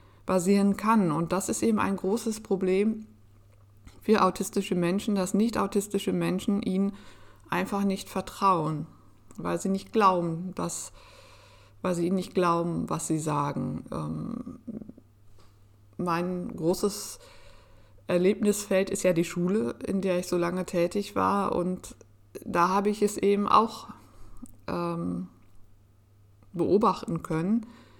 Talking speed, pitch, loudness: 125 wpm, 180 Hz, -27 LUFS